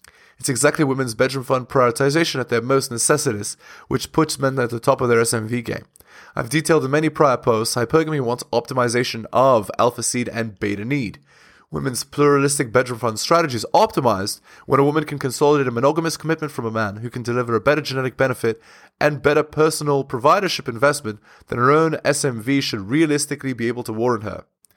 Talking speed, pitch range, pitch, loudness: 185 wpm, 120-150 Hz, 135 Hz, -20 LUFS